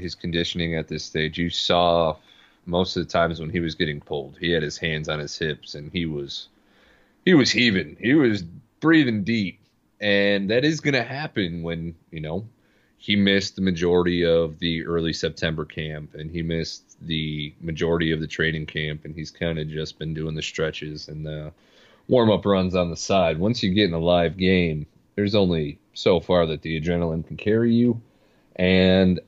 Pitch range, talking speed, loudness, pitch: 80-95 Hz, 195 wpm, -23 LUFS, 85 Hz